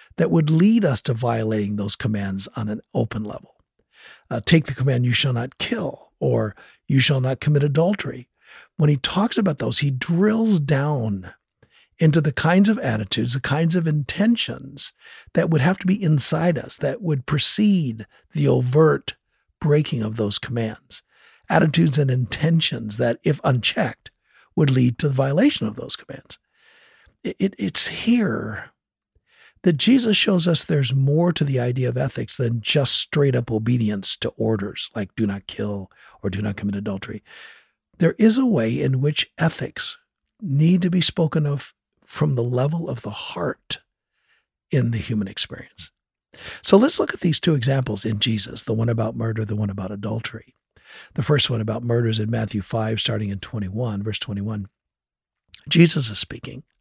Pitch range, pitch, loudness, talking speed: 110-160 Hz, 130 Hz, -21 LUFS, 170 wpm